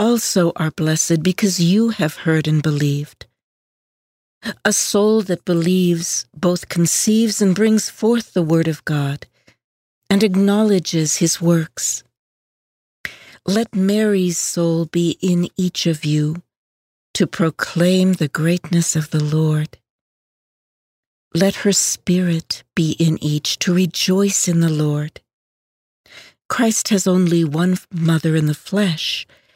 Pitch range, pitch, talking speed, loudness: 155-195 Hz, 170 Hz, 120 wpm, -18 LUFS